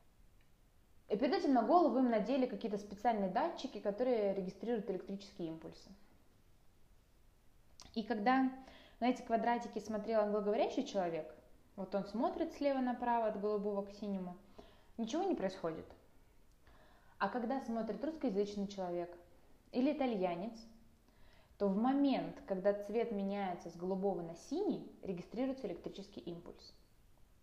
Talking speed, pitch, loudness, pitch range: 120 wpm, 215 Hz, -38 LUFS, 195-250 Hz